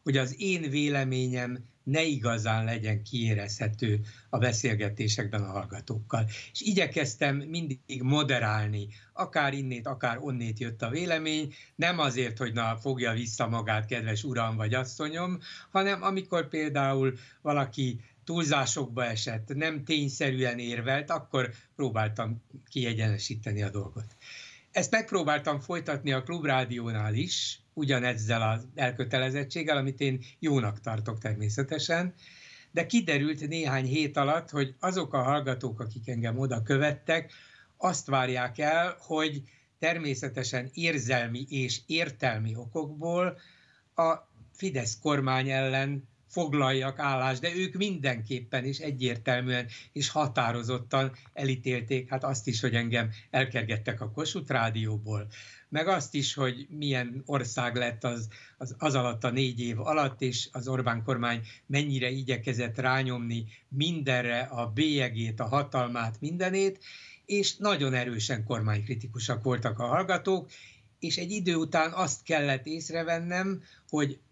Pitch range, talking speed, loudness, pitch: 120-150 Hz, 120 wpm, -30 LUFS, 130 Hz